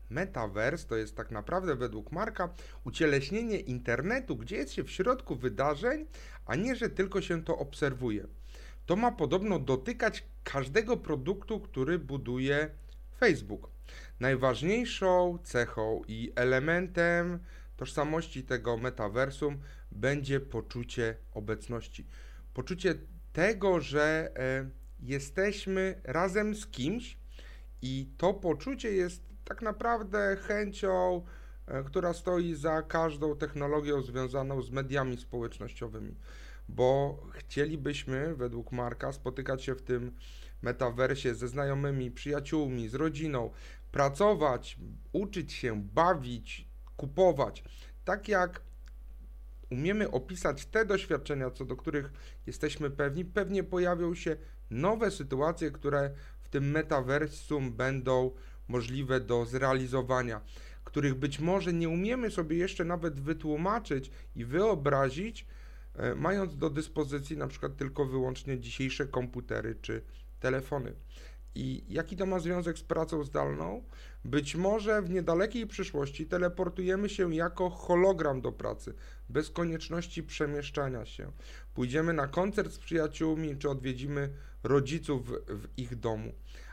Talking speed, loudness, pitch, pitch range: 115 wpm, -33 LUFS, 145 Hz, 125-175 Hz